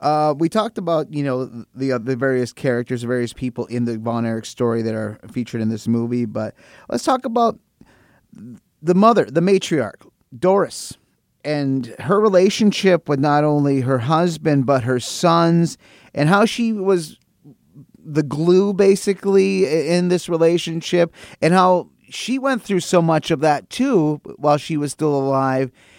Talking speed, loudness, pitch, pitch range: 160 wpm, -19 LUFS, 155 Hz, 130-180 Hz